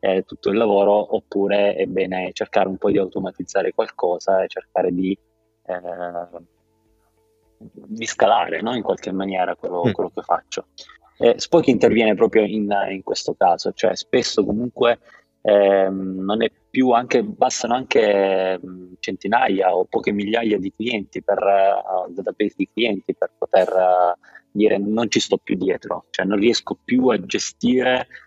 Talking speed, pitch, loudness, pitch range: 155 wpm, 100 Hz, -20 LUFS, 95-110 Hz